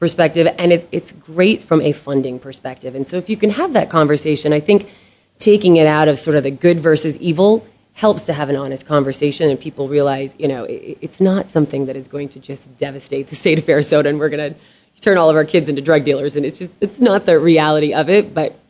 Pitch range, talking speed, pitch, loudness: 145-175 Hz, 235 wpm, 155 Hz, -15 LUFS